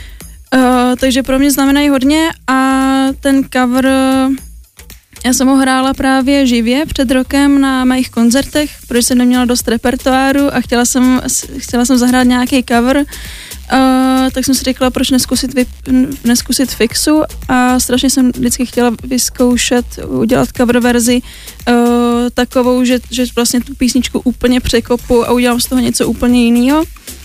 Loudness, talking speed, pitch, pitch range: -11 LUFS, 150 wpm, 255 Hz, 245-265 Hz